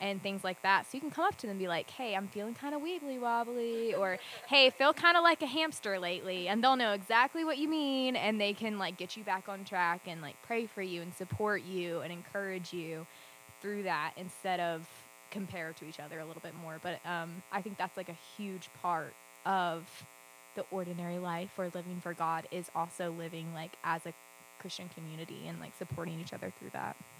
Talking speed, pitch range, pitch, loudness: 225 wpm, 165-210 Hz, 185 Hz, -34 LUFS